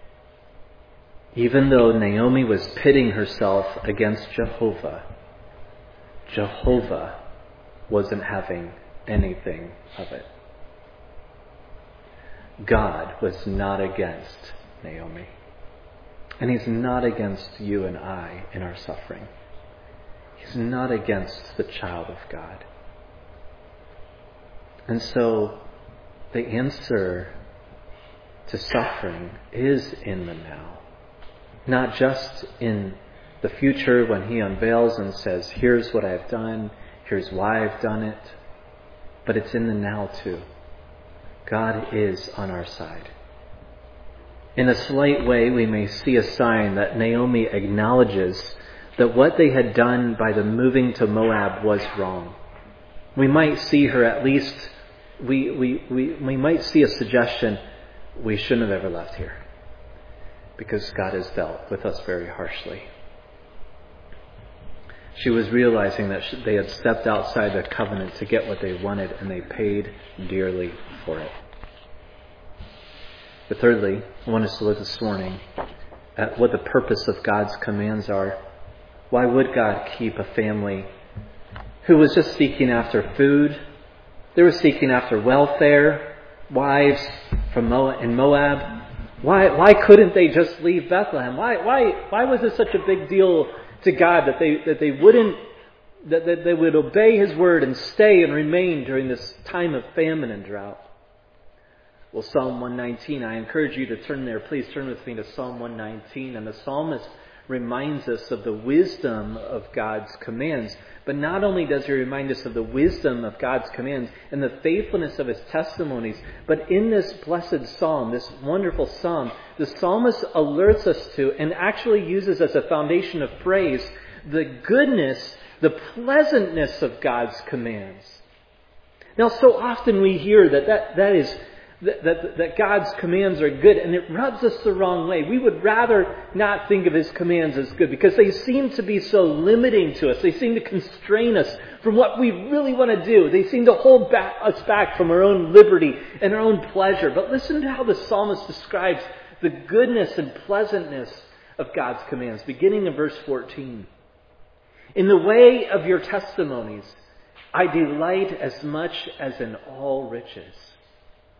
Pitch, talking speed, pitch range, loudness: 125 Hz, 150 wpm, 100-170 Hz, -20 LUFS